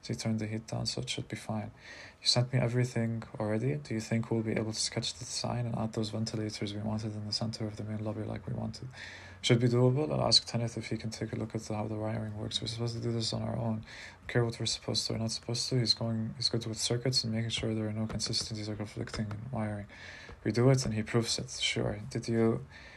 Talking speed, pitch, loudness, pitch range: 265 wpm, 110 Hz, -32 LUFS, 110-115 Hz